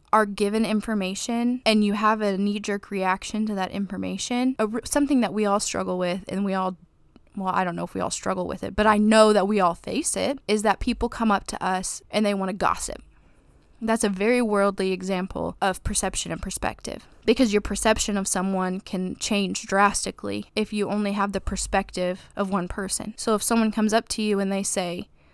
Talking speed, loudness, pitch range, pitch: 210 wpm, -24 LUFS, 190-220 Hz, 205 Hz